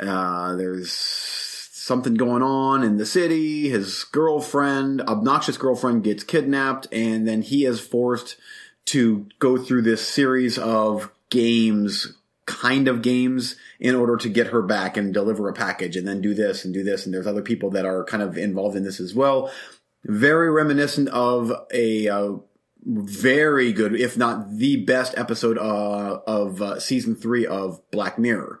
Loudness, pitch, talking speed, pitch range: -22 LUFS, 120 Hz, 165 wpm, 105-135 Hz